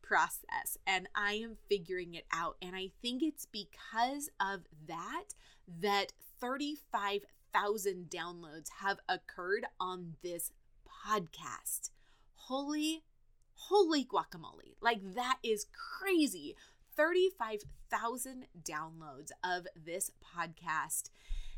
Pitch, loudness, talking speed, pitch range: 205 Hz, -37 LUFS, 95 wpm, 180-300 Hz